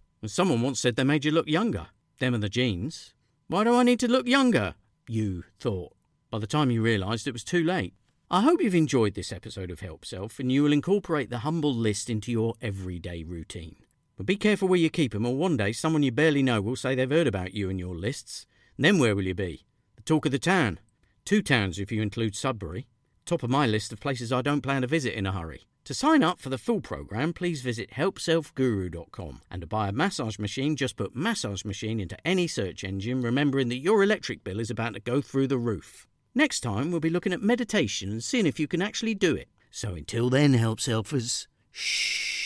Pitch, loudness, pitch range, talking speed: 125 Hz, -27 LUFS, 105-160 Hz, 225 wpm